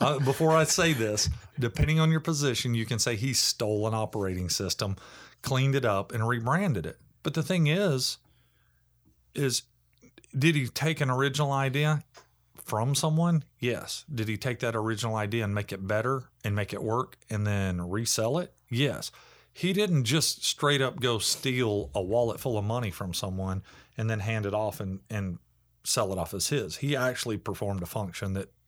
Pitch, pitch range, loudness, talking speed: 120 Hz, 105-140 Hz, -28 LUFS, 185 wpm